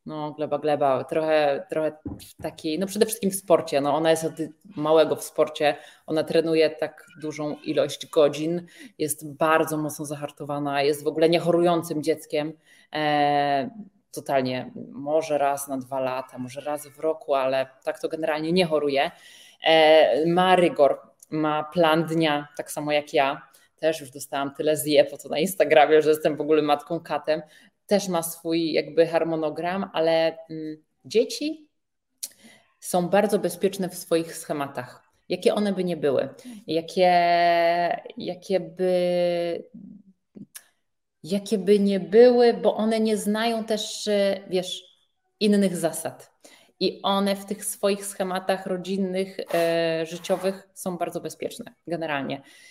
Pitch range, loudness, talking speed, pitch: 150-185 Hz, -24 LUFS, 135 wpm, 160 Hz